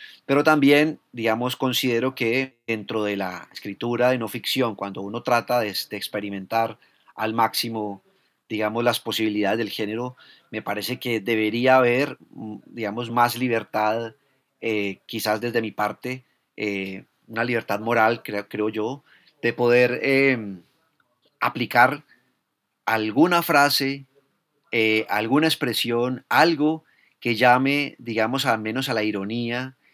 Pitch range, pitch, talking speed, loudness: 110-130 Hz, 120 Hz, 125 wpm, -23 LUFS